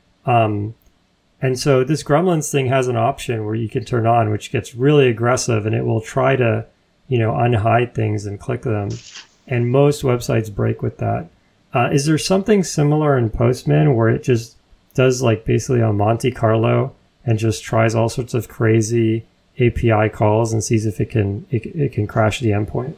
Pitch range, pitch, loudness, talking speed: 110-130 Hz, 120 Hz, -18 LUFS, 190 wpm